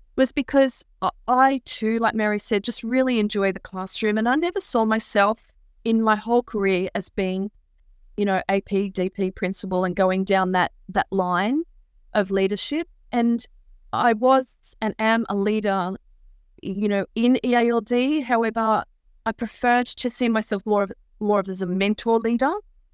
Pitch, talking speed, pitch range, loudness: 215 Hz, 160 wpm, 195-240 Hz, -22 LUFS